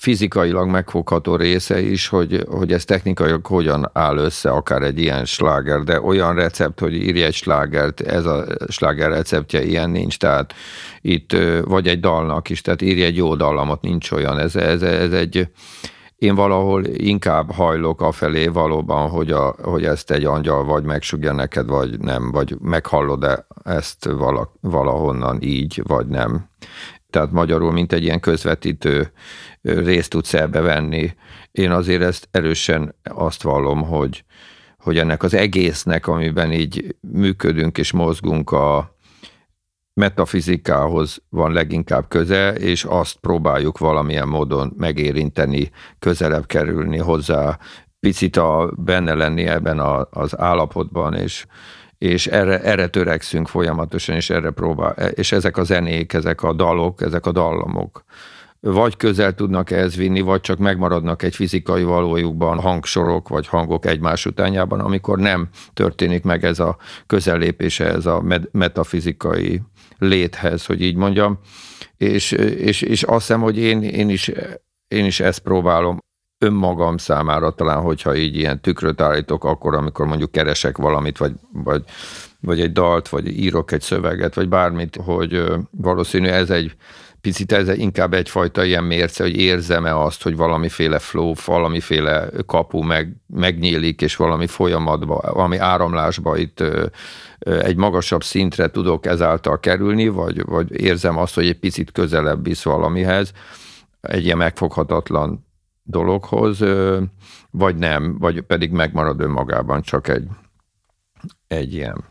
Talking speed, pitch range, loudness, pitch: 140 wpm, 80-95 Hz, -18 LUFS, 85 Hz